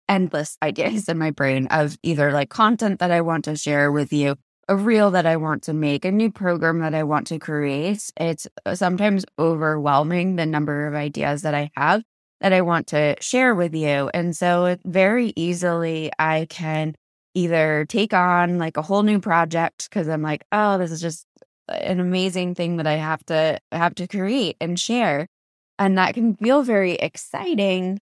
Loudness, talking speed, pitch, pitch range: -21 LUFS, 190 wpm, 170 Hz, 155-190 Hz